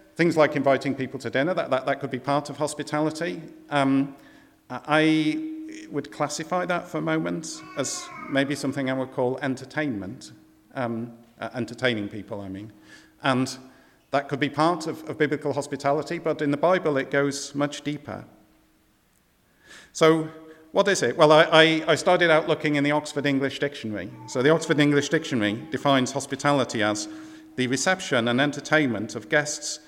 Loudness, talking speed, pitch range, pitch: -24 LUFS, 165 wpm, 130-155 Hz, 145 Hz